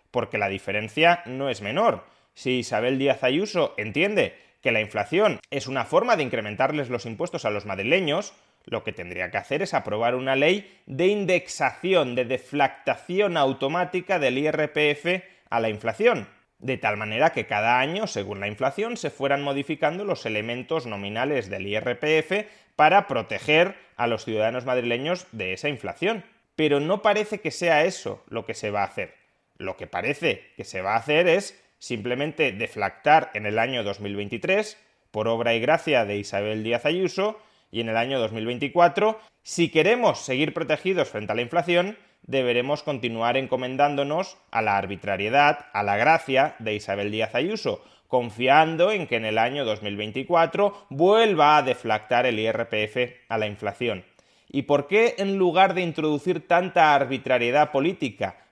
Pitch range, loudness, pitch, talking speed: 115-175 Hz, -24 LUFS, 135 Hz, 160 wpm